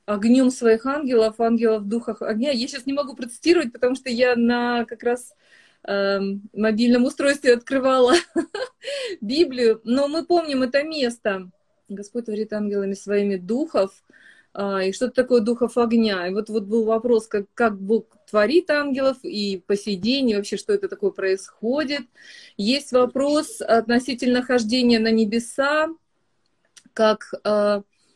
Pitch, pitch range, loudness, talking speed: 240 Hz, 215-270 Hz, -21 LUFS, 135 wpm